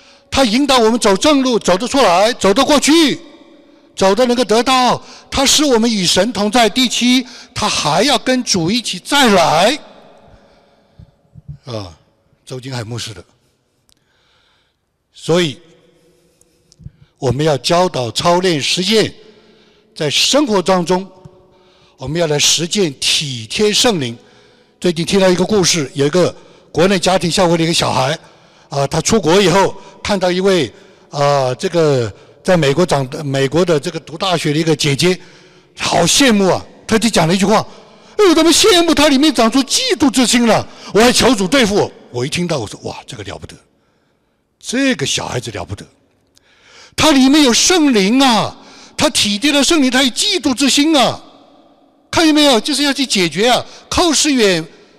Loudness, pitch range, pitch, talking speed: -13 LUFS, 165-255 Hz, 190 Hz, 235 characters per minute